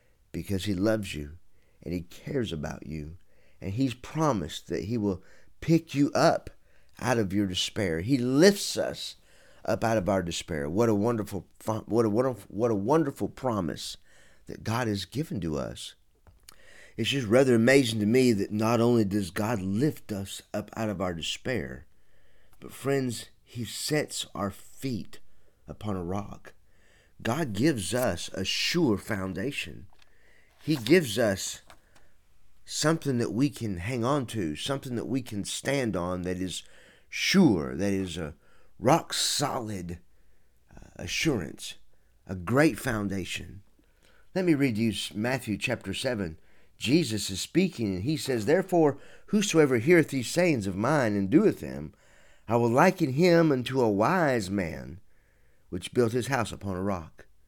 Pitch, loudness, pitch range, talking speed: 110 Hz, -28 LUFS, 95-135 Hz, 150 wpm